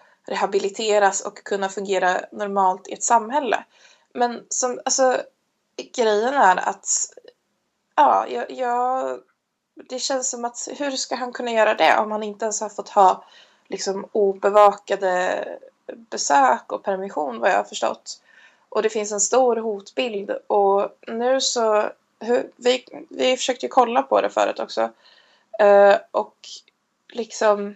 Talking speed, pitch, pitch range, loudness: 135 wpm, 220 Hz, 200-255 Hz, -21 LUFS